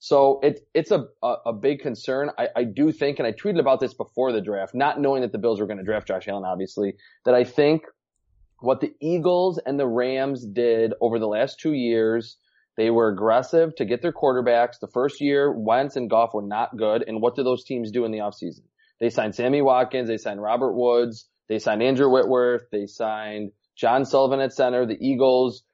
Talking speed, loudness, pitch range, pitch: 210 wpm, -23 LUFS, 110-135 Hz, 125 Hz